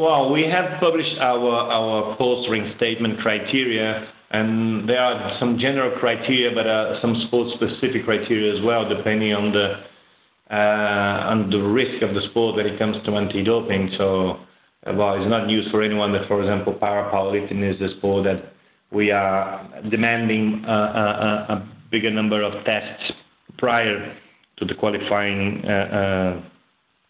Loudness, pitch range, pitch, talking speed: -21 LUFS, 100-115 Hz, 105 Hz, 155 wpm